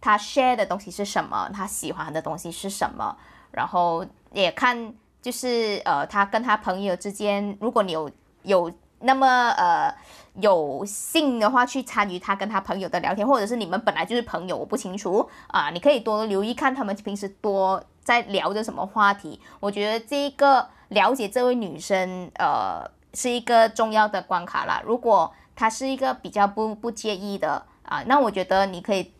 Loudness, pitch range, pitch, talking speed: -24 LUFS, 195-245 Hz, 210 Hz, 285 characters per minute